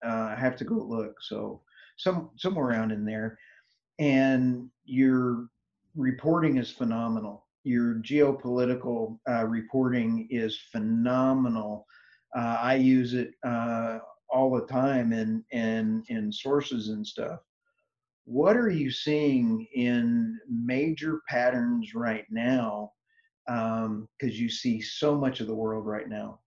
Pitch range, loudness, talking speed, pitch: 115-145 Hz, -28 LUFS, 130 wpm, 125 Hz